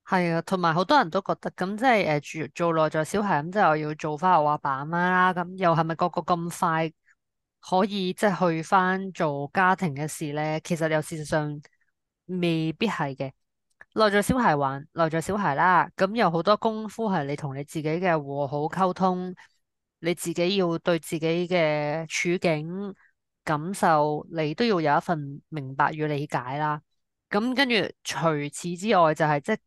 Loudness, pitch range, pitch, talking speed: -25 LUFS, 155-185 Hz, 170 Hz, 260 characters per minute